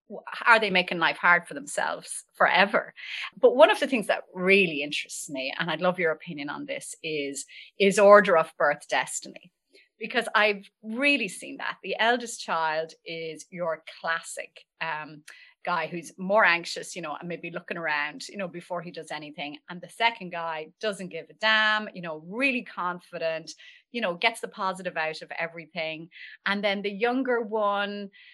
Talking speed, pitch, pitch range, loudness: 175 wpm, 180 Hz, 160-215 Hz, -26 LUFS